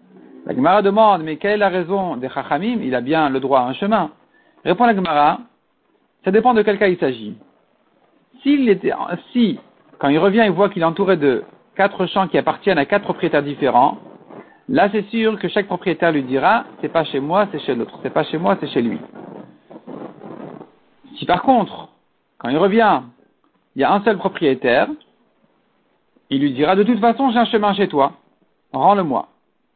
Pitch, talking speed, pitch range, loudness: 195 Hz, 185 wpm, 150-215 Hz, -17 LUFS